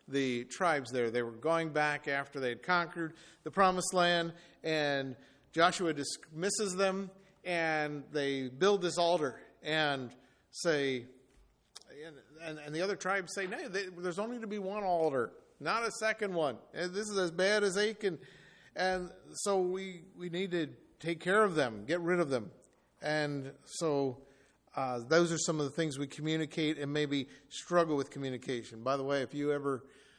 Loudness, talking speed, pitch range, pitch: -34 LUFS, 170 wpm, 140-185 Hz, 160 Hz